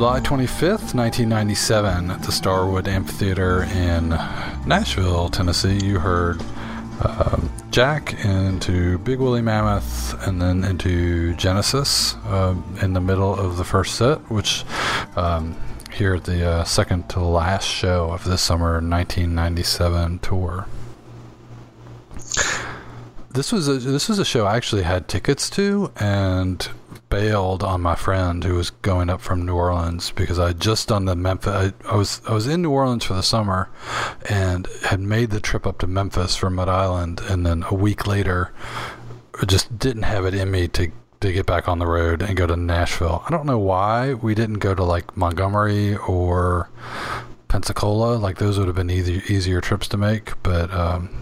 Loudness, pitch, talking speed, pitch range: -21 LUFS, 95 Hz, 170 wpm, 90-110 Hz